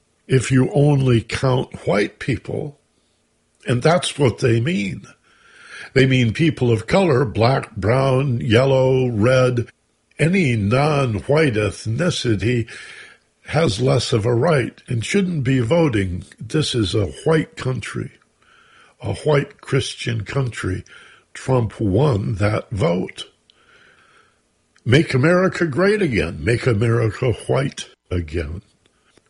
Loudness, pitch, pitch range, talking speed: -19 LUFS, 130 Hz, 110-145 Hz, 110 wpm